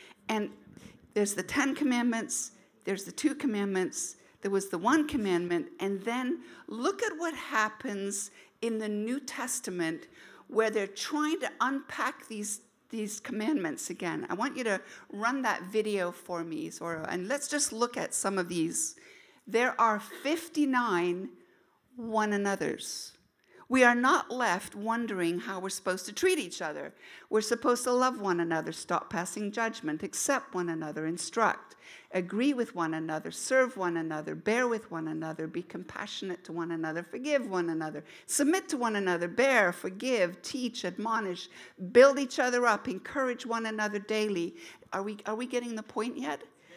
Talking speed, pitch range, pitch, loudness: 160 wpm, 185-260 Hz, 220 Hz, -31 LUFS